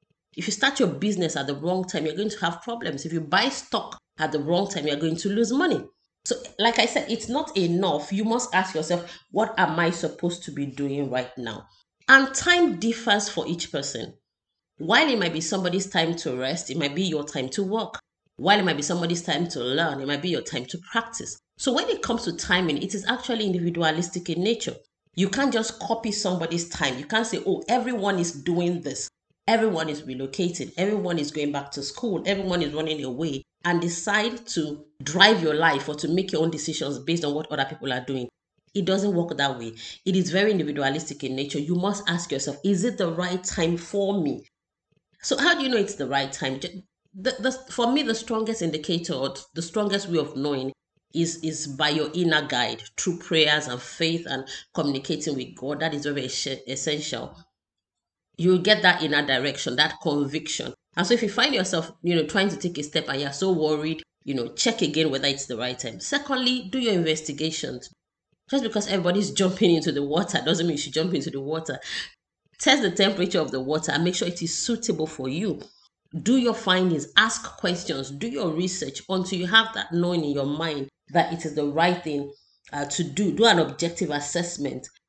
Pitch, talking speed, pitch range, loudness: 170 Hz, 210 wpm, 150-200 Hz, -25 LUFS